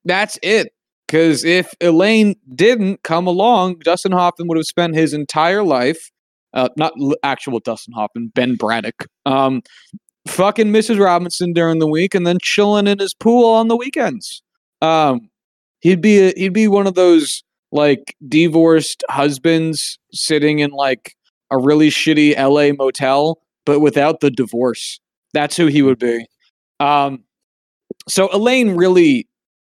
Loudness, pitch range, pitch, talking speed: -15 LUFS, 140-190 Hz, 160 Hz, 145 wpm